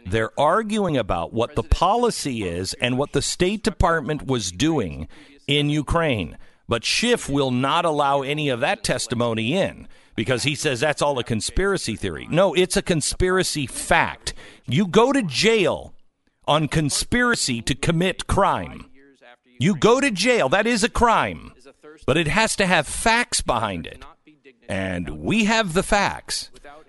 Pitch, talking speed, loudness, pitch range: 150 Hz, 155 wpm, -21 LUFS, 125-195 Hz